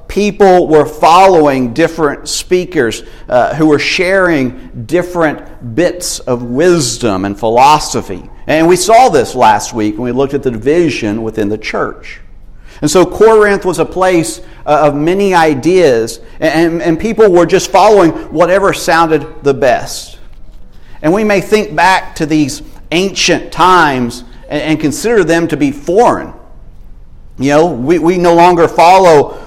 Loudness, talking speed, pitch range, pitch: -10 LUFS, 150 wpm, 130-175 Hz, 155 Hz